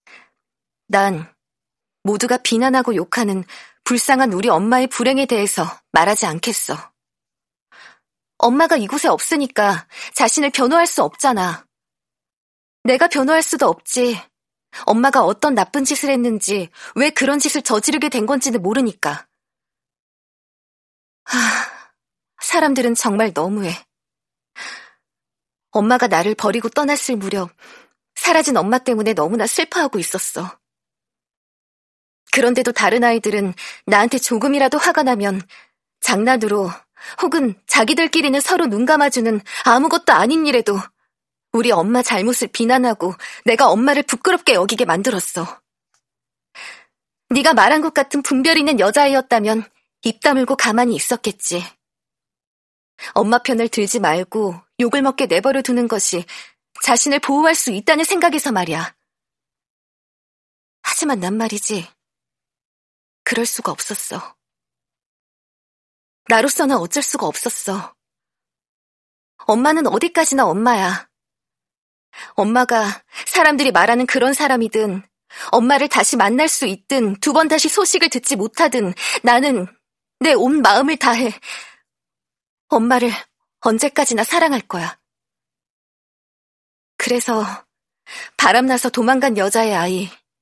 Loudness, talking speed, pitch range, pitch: -16 LUFS, 255 characters per minute, 210-285 Hz, 245 Hz